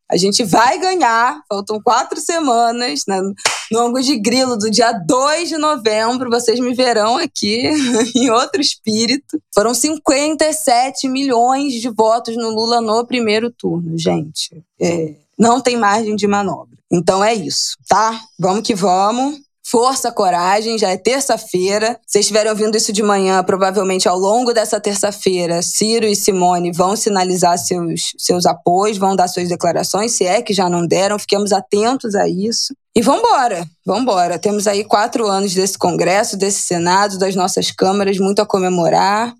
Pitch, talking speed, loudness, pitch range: 215 Hz, 155 wpm, -15 LUFS, 190-240 Hz